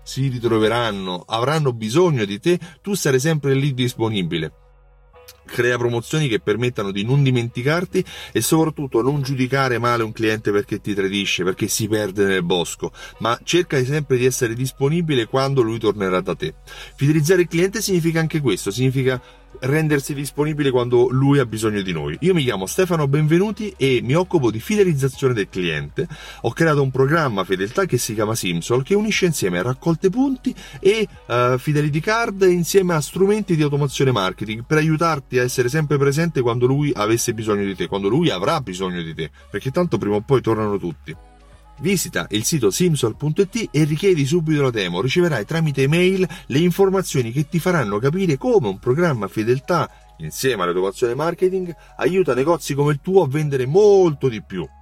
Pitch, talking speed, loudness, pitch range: 135 Hz, 170 wpm, -19 LUFS, 115-170 Hz